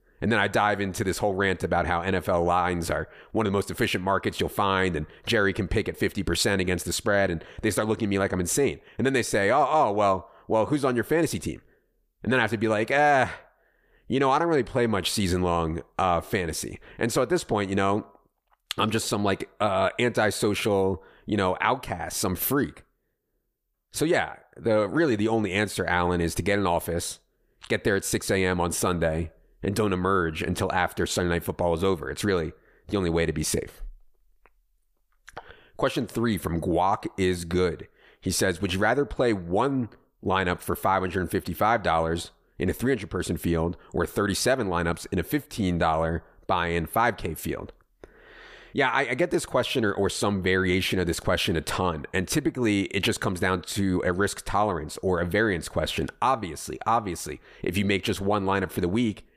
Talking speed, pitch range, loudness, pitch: 200 wpm, 85-105 Hz, -26 LUFS, 95 Hz